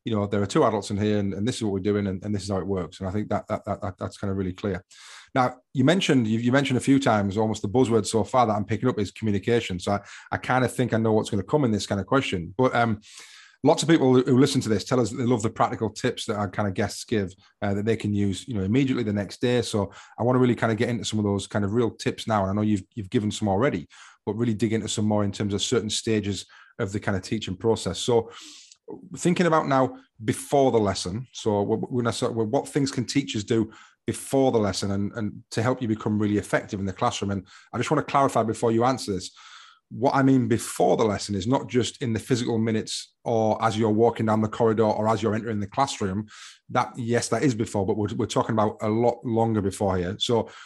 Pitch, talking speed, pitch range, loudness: 110 Hz, 270 wpm, 105-125 Hz, -25 LUFS